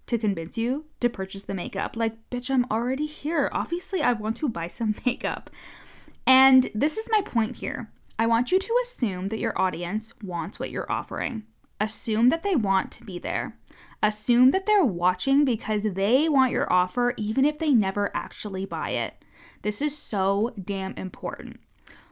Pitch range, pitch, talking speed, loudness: 205-270 Hz, 230 Hz, 175 wpm, -25 LUFS